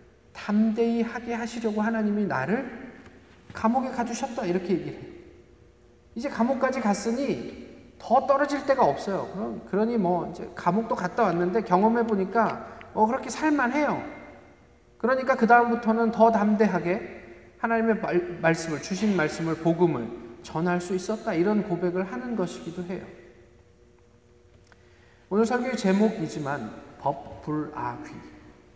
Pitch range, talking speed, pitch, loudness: 165-235 Hz, 285 characters per minute, 210 Hz, -26 LUFS